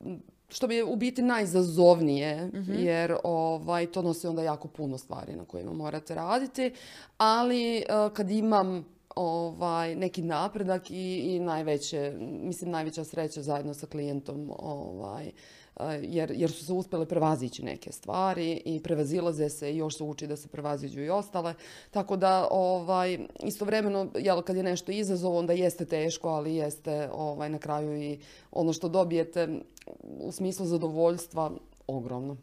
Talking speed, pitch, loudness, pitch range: 145 wpm, 170 Hz, -30 LUFS, 150-185 Hz